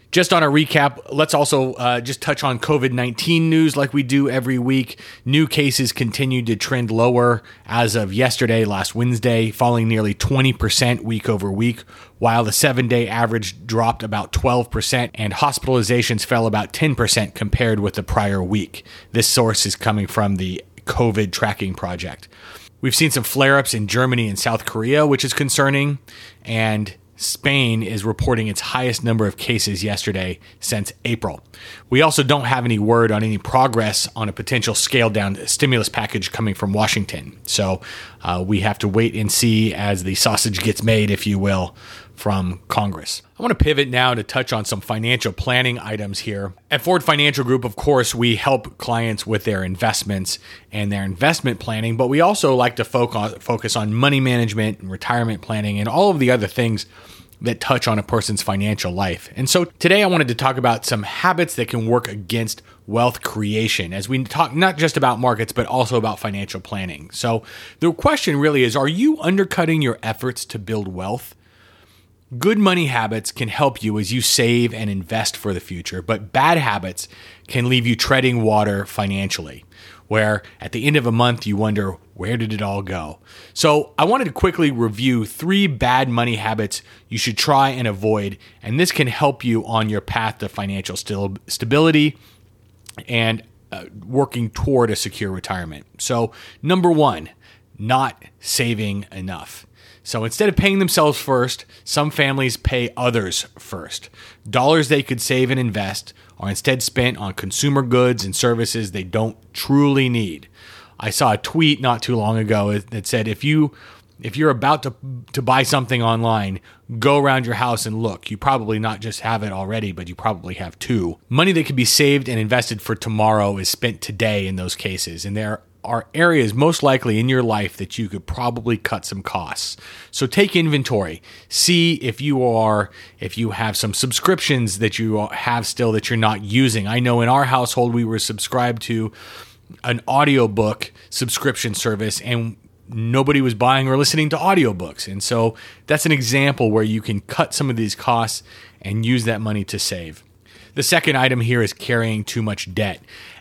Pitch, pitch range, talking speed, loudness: 115 Hz, 105-130 Hz, 180 wpm, -19 LUFS